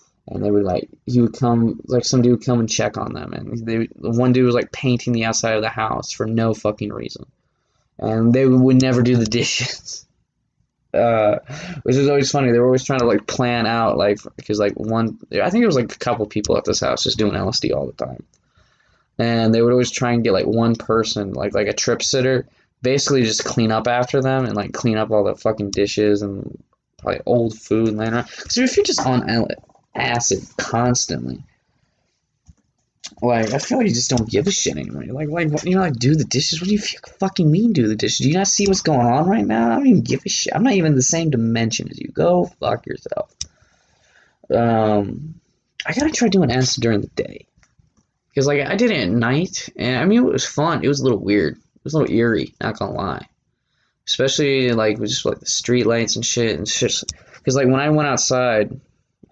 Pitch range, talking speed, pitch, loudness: 110-135 Hz, 225 wpm, 120 Hz, -19 LUFS